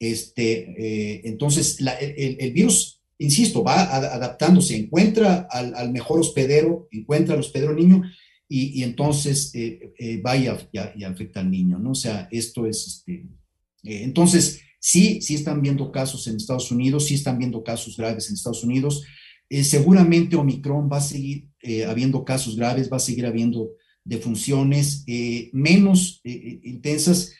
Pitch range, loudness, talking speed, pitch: 115-150 Hz, -21 LUFS, 160 wpm, 135 Hz